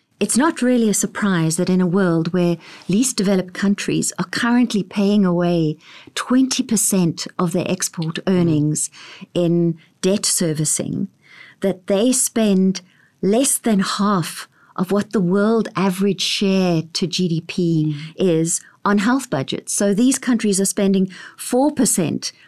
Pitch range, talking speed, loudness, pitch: 175-210 Hz, 130 wpm, -18 LUFS, 195 Hz